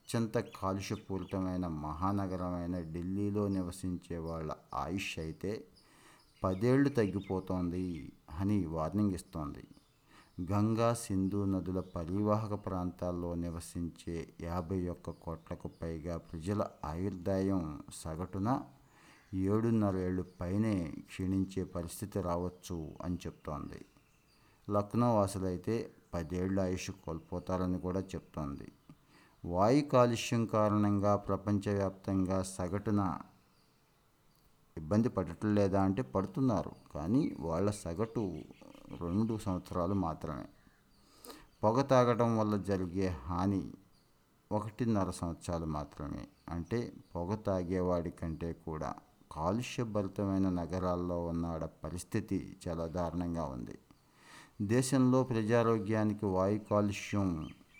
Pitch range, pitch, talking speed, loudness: 85-105 Hz, 95 Hz, 85 wpm, -35 LUFS